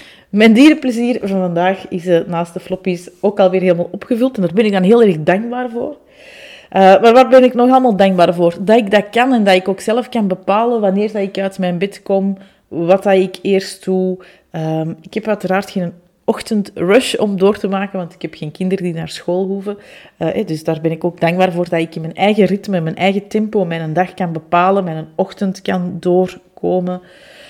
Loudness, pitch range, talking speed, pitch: -15 LUFS, 180-205 Hz, 215 wpm, 190 Hz